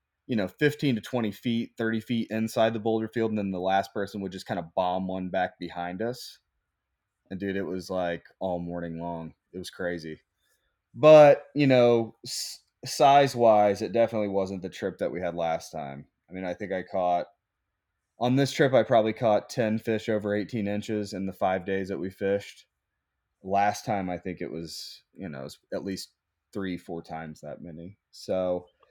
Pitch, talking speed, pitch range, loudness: 100 Hz, 195 wpm, 90-110 Hz, -26 LUFS